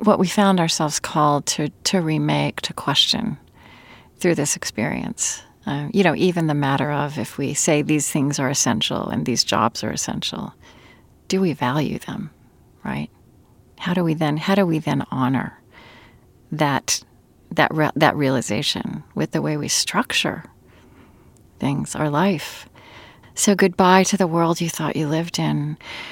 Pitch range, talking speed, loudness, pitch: 140-175 Hz, 160 wpm, -20 LUFS, 150 Hz